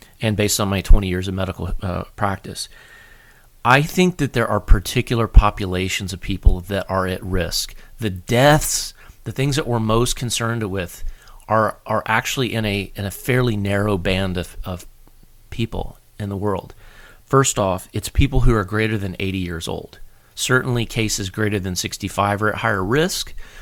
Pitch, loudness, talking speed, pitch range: 105 Hz, -20 LUFS, 175 wpm, 95-115 Hz